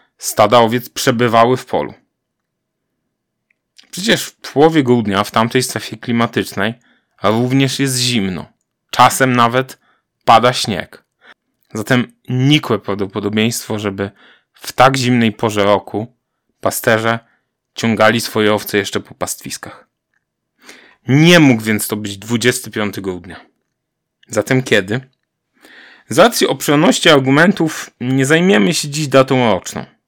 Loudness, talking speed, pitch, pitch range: -14 LUFS, 110 wpm, 115 Hz, 105-130 Hz